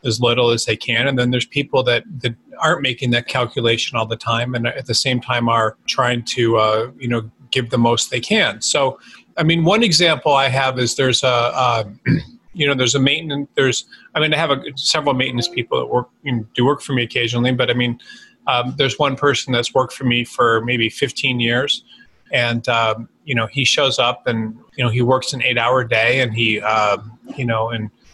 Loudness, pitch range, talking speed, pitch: -17 LUFS, 115-135 Hz, 225 wpm, 125 Hz